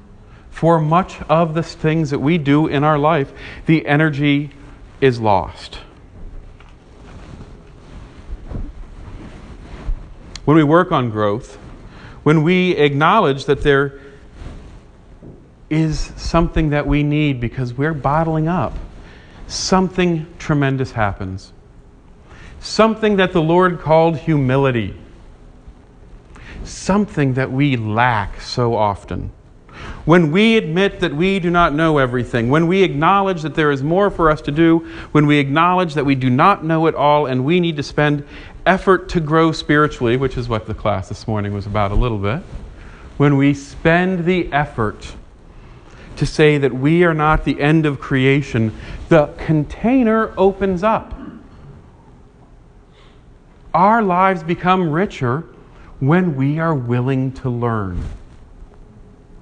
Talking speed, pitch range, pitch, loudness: 130 wpm, 115-165 Hz, 145 Hz, -16 LUFS